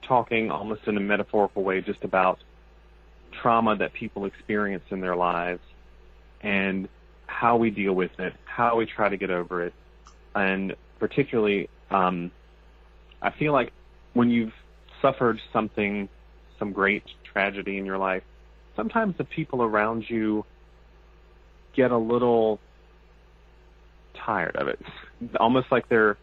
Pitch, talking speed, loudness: 95 Hz, 135 wpm, -26 LUFS